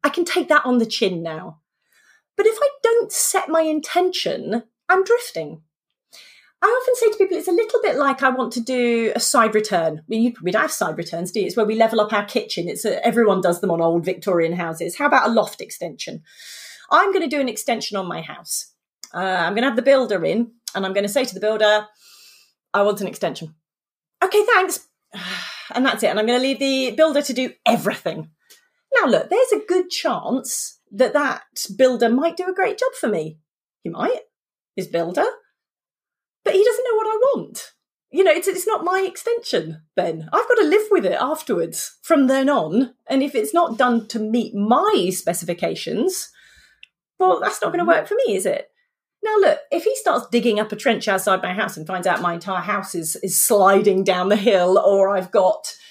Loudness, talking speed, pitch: -19 LUFS, 215 wpm, 245 Hz